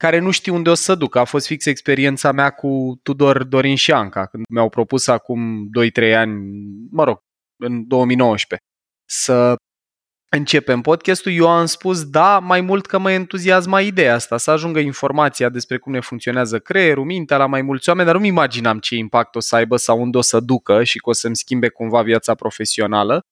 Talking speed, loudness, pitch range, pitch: 195 wpm, -16 LUFS, 115-160 Hz, 130 Hz